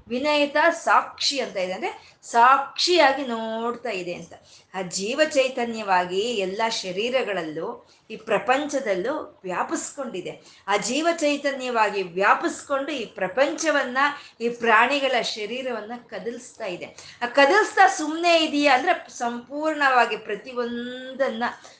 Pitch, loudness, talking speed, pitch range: 250 Hz, -23 LUFS, 95 wpm, 220-290 Hz